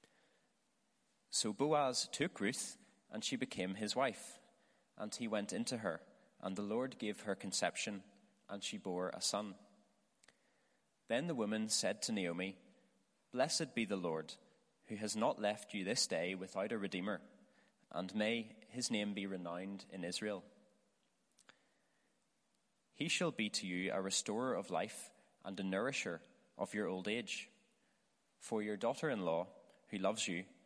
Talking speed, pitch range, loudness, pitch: 150 wpm, 95-110 Hz, -40 LUFS, 105 Hz